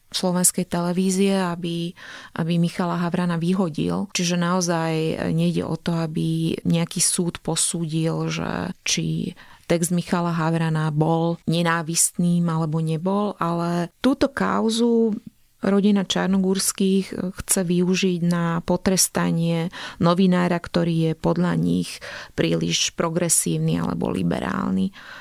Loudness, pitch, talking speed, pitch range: -22 LUFS, 175 Hz, 100 wpm, 165-185 Hz